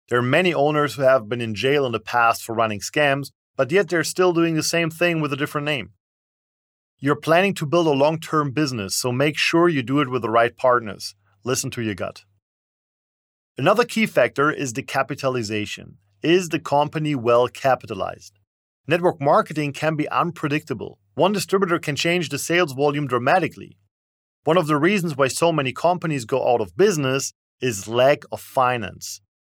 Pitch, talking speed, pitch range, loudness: 140 Hz, 180 wpm, 115-155 Hz, -21 LUFS